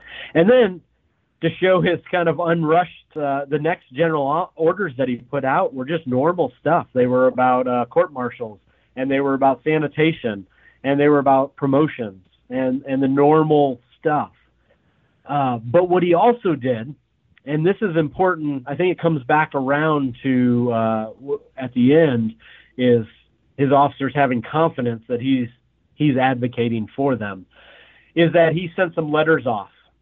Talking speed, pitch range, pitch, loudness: 165 wpm, 125-165 Hz, 140 Hz, -19 LUFS